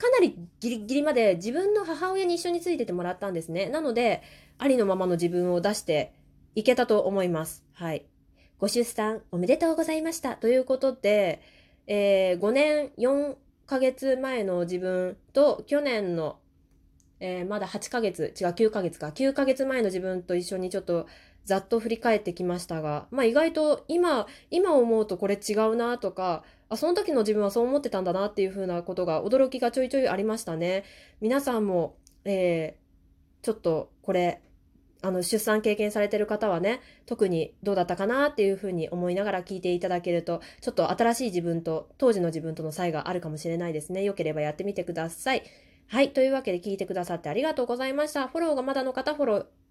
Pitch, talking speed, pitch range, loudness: 205 Hz, 390 characters per minute, 180-260 Hz, -27 LUFS